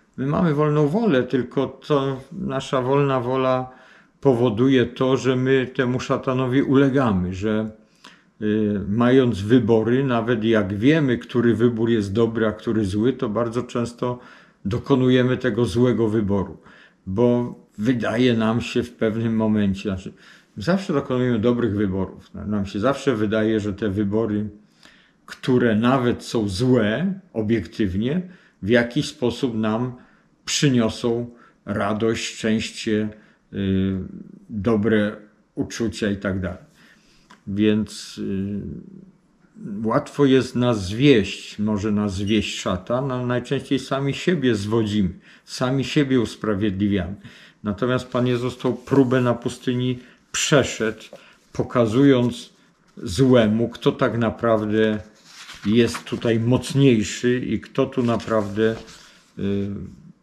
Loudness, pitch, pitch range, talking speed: -21 LUFS, 120 Hz, 110-130 Hz, 115 wpm